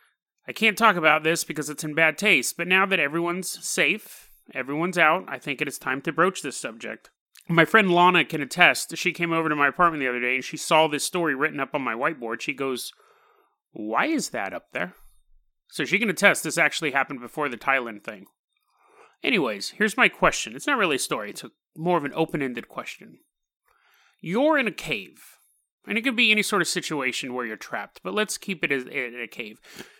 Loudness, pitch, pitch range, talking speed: -23 LUFS, 160 Hz, 140-180 Hz, 210 wpm